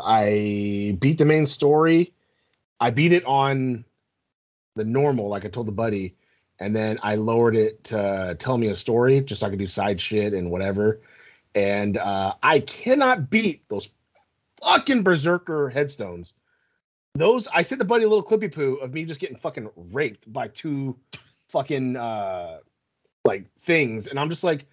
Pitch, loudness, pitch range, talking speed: 130 Hz, -23 LUFS, 105-160 Hz, 165 wpm